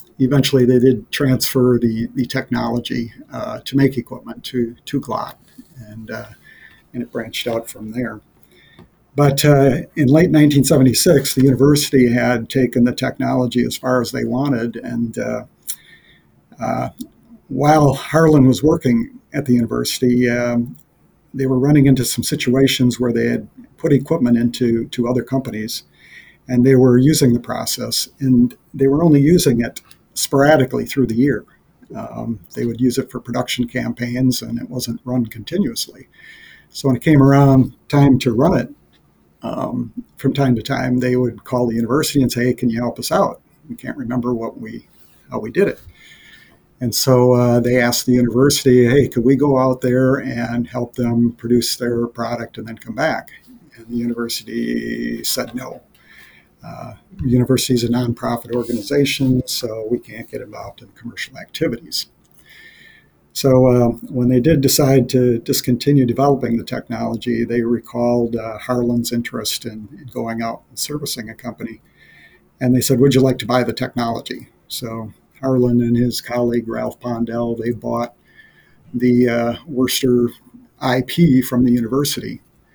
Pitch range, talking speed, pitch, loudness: 120-135 Hz, 160 wpm, 125 Hz, -17 LUFS